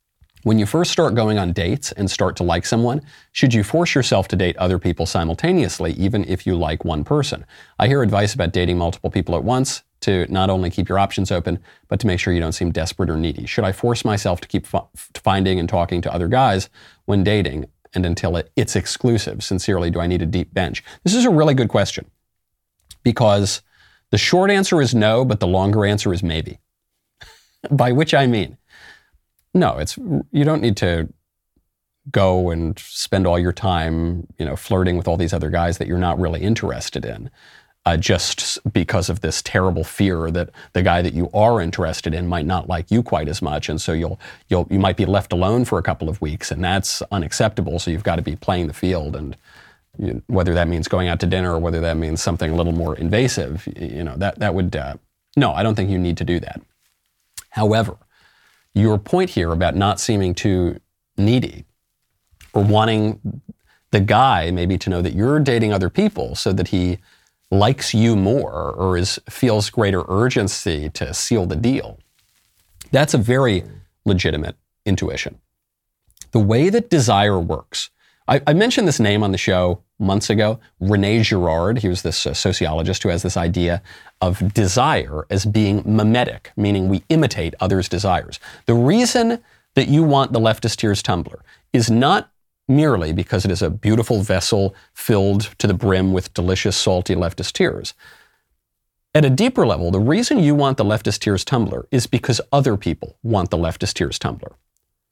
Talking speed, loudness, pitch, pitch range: 190 wpm, -19 LUFS, 95 Hz, 85-110 Hz